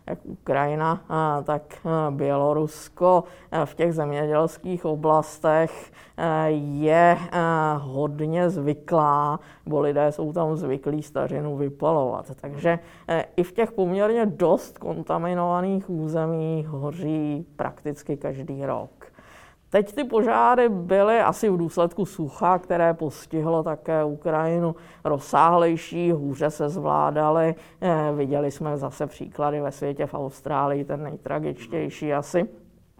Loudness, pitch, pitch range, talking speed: -24 LUFS, 155 Hz, 145-170 Hz, 105 wpm